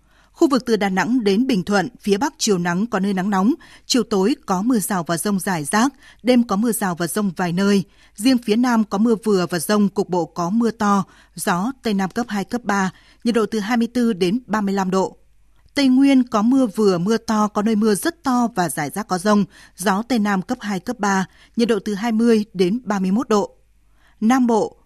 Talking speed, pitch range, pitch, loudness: 225 wpm, 195-235 Hz, 210 Hz, -19 LUFS